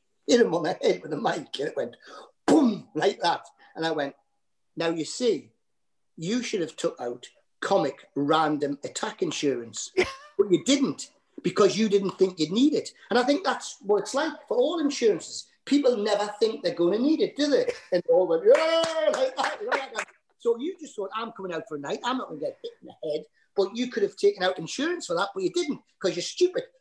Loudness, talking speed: -26 LUFS, 230 wpm